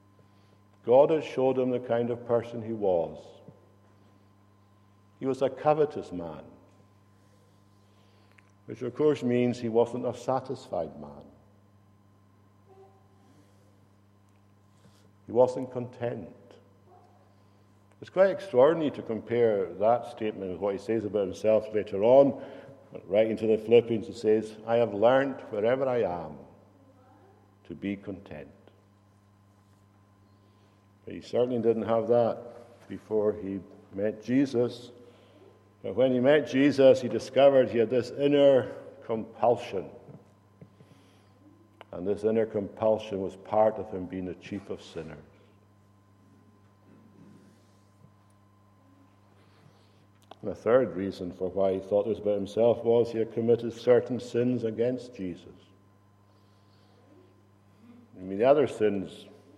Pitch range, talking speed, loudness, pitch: 100-115 Hz, 115 wpm, -27 LUFS, 105 Hz